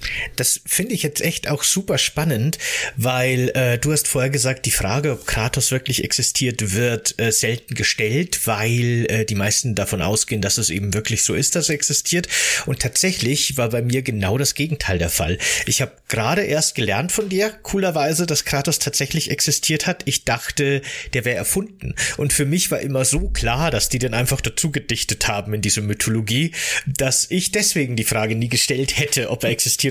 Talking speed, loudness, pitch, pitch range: 190 wpm, -19 LUFS, 130 Hz, 115-150 Hz